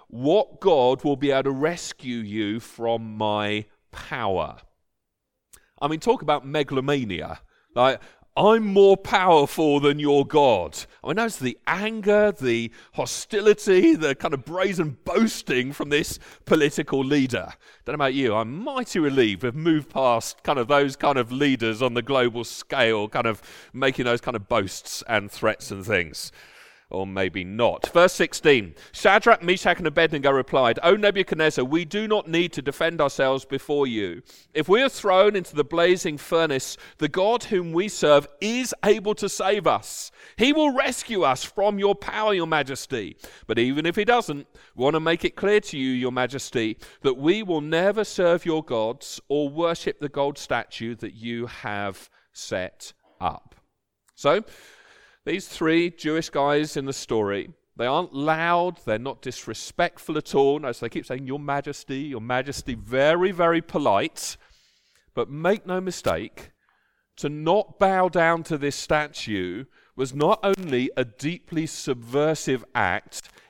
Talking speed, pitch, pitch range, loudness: 160 wpm, 150 Hz, 130-180 Hz, -23 LUFS